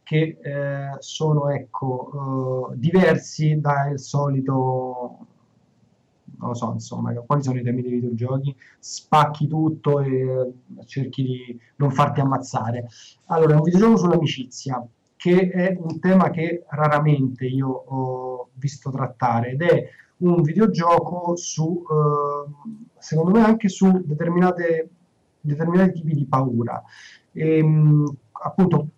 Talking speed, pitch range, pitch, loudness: 120 wpm, 130-165 Hz, 145 Hz, -21 LUFS